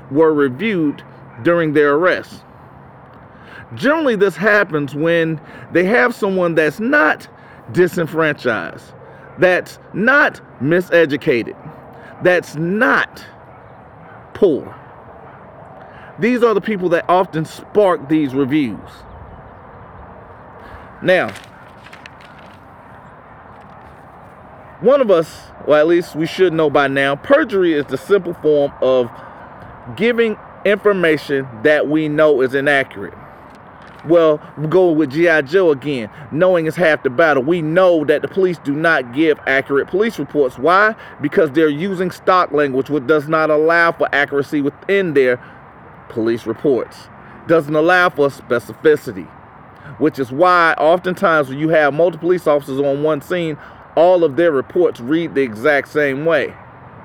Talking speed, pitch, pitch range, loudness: 125 wpm, 155 Hz, 140-180 Hz, -15 LUFS